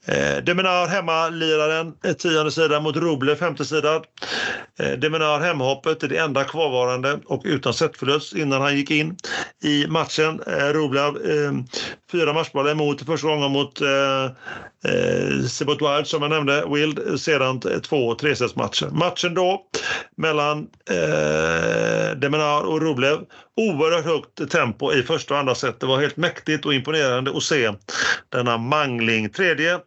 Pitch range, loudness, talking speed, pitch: 140-160 Hz, -21 LUFS, 135 wpm, 150 Hz